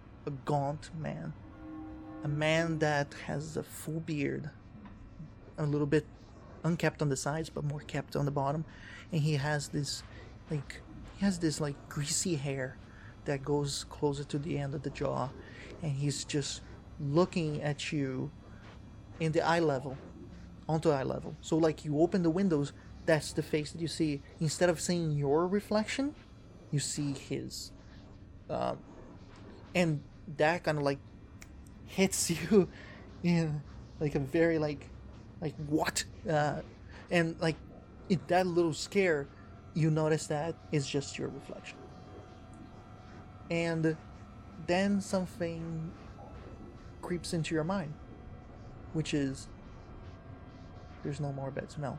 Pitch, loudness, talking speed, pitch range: 145 Hz, -33 LUFS, 140 wpm, 105-160 Hz